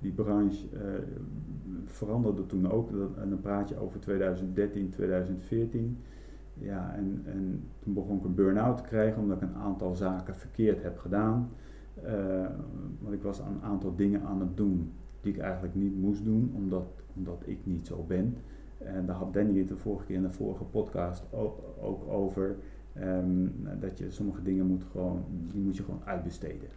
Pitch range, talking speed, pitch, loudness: 95-100 Hz, 180 wpm, 95 Hz, -33 LUFS